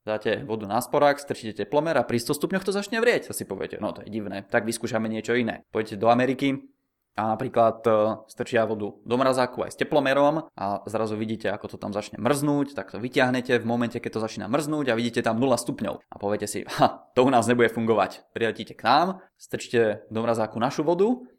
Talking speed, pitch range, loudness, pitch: 210 wpm, 110-135 Hz, -25 LUFS, 115 Hz